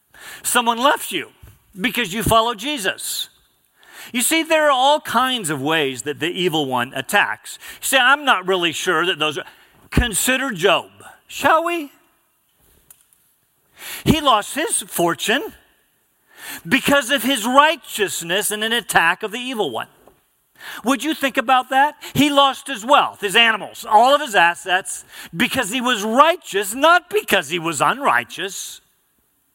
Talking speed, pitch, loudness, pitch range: 145 wpm, 250 Hz, -18 LUFS, 195-285 Hz